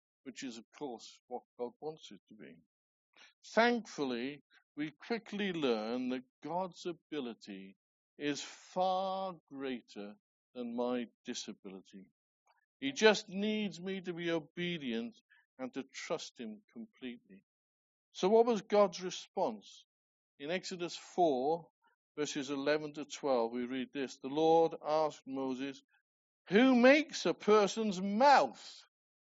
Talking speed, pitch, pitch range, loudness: 120 wpm, 165 Hz, 130-215 Hz, -34 LUFS